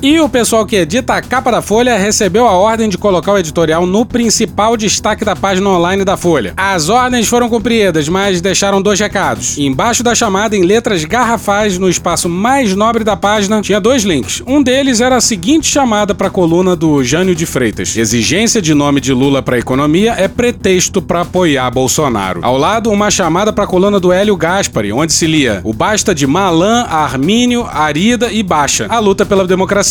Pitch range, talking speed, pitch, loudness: 170-225 Hz, 195 wpm, 200 Hz, -11 LUFS